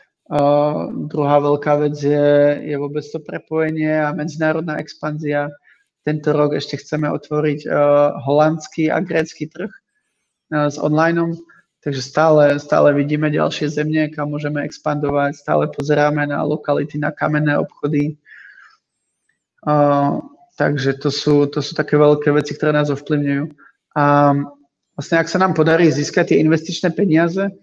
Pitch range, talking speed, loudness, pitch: 145-155 Hz, 135 wpm, -17 LUFS, 150 Hz